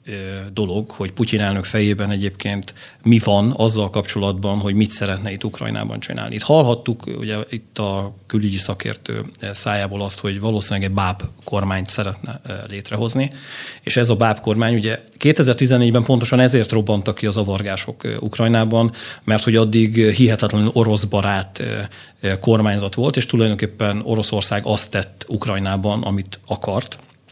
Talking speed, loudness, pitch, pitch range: 135 wpm, -18 LUFS, 105 Hz, 100-115 Hz